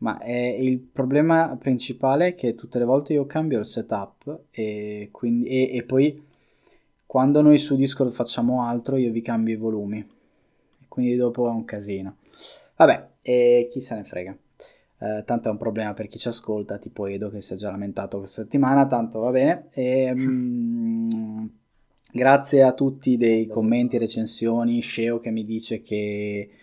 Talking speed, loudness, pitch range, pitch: 170 wpm, -23 LUFS, 110-130 Hz, 120 Hz